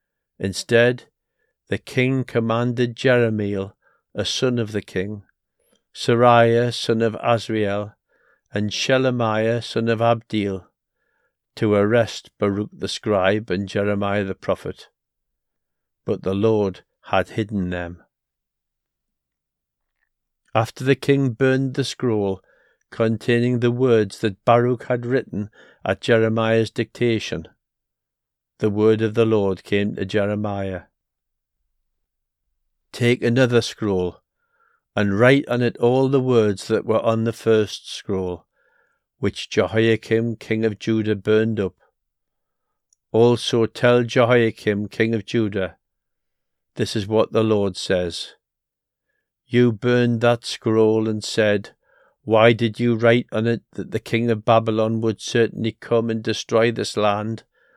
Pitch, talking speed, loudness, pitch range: 110 Hz, 120 wpm, -20 LUFS, 100-120 Hz